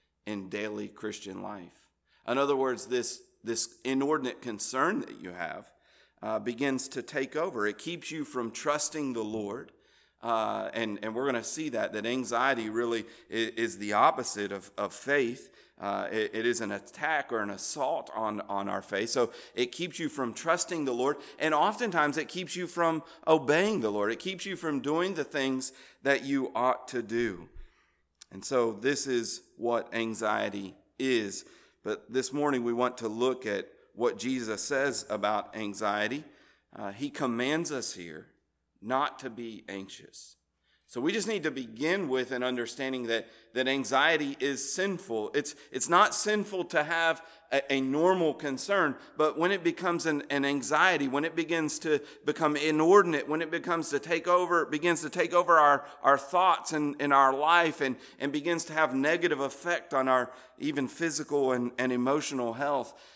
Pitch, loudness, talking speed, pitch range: 135 Hz, -29 LUFS, 175 wpm, 120-155 Hz